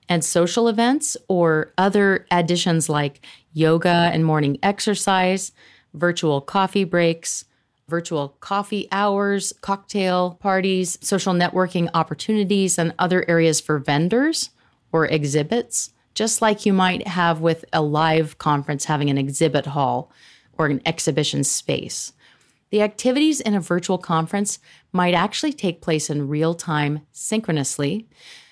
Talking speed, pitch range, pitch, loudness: 125 wpm, 155-200 Hz, 175 Hz, -21 LUFS